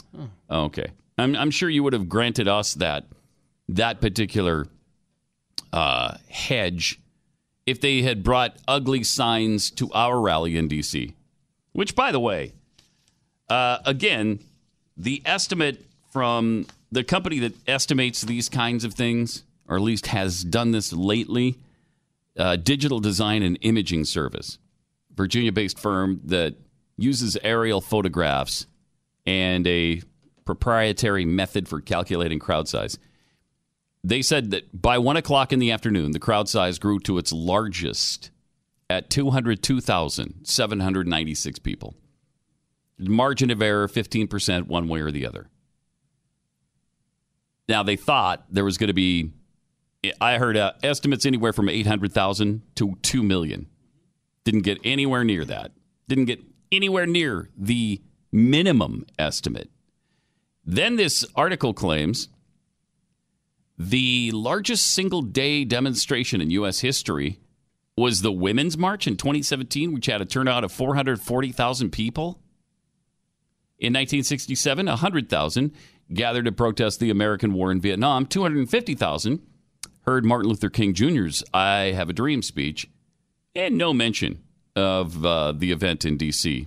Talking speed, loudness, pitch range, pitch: 125 wpm, -23 LUFS, 95-135 Hz, 115 Hz